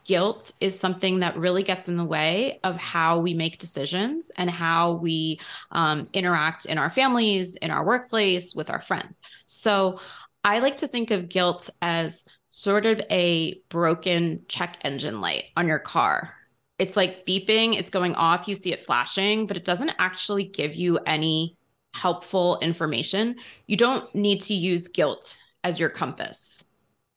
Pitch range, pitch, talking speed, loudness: 170-205 Hz, 185 Hz, 165 wpm, -24 LUFS